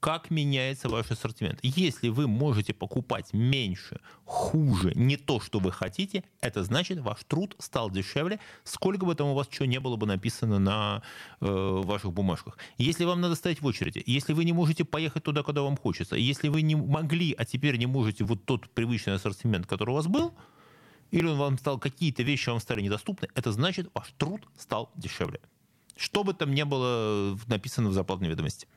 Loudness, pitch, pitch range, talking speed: -29 LUFS, 130 Hz, 110-155 Hz, 190 wpm